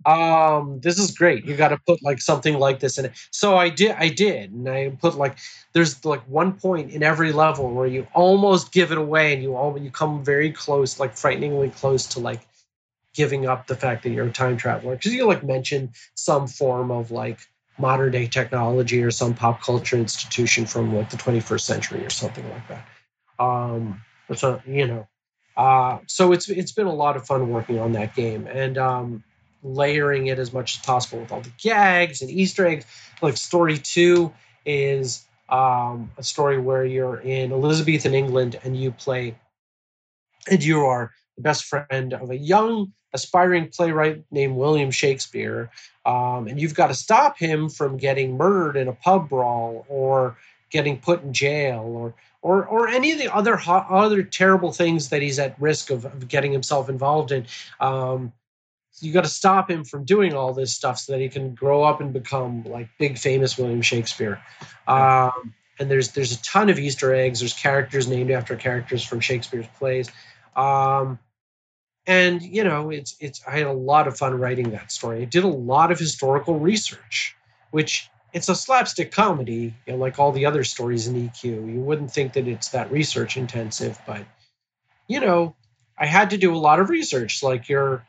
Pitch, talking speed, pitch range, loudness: 135 Hz, 190 wpm, 125-155 Hz, -21 LUFS